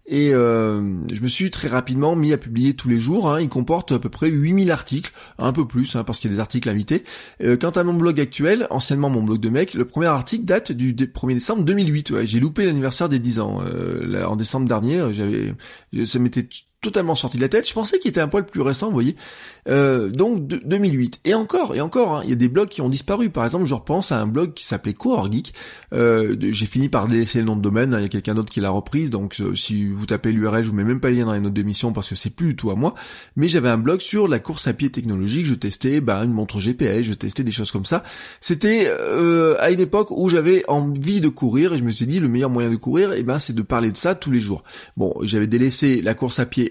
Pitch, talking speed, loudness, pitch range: 125 Hz, 270 wpm, -20 LUFS, 115-160 Hz